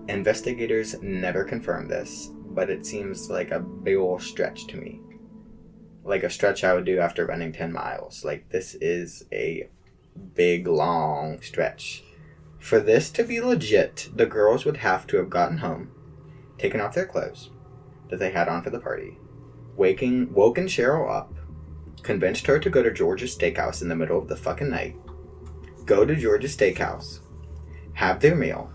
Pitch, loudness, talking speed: 110 Hz, -25 LUFS, 165 wpm